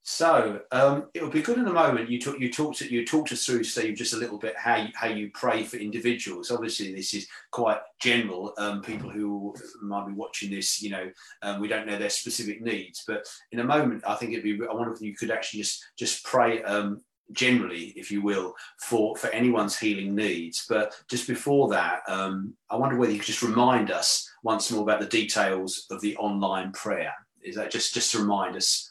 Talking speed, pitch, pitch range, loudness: 220 wpm, 105 Hz, 100-120 Hz, -27 LUFS